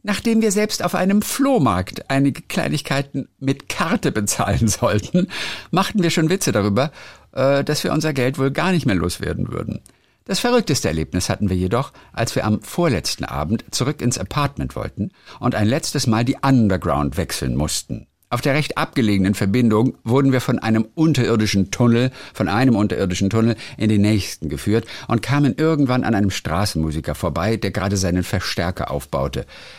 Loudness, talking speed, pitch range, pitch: -20 LUFS, 165 wpm, 100-140 Hz, 115 Hz